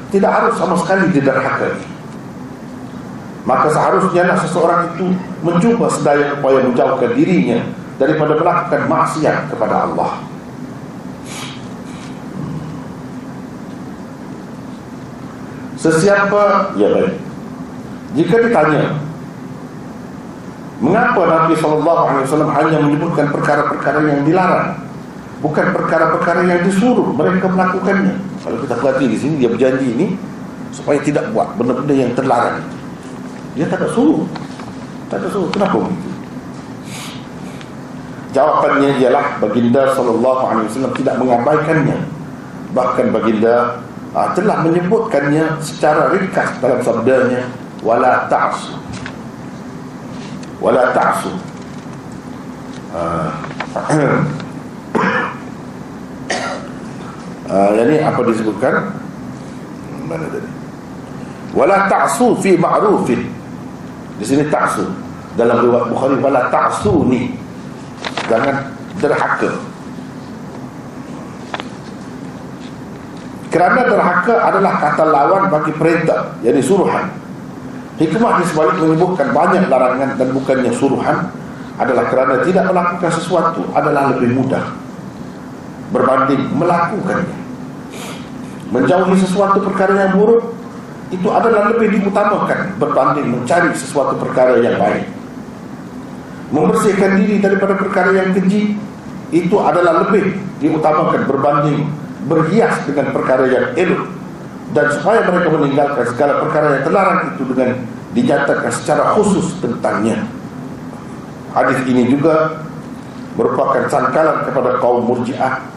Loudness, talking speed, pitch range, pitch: -14 LUFS, 95 wpm, 135-190 Hz, 160 Hz